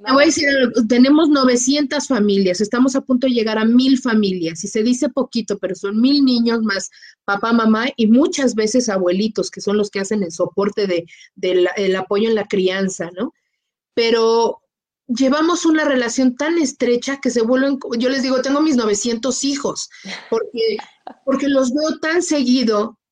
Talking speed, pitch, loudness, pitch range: 170 wpm, 245 Hz, -17 LUFS, 210-275 Hz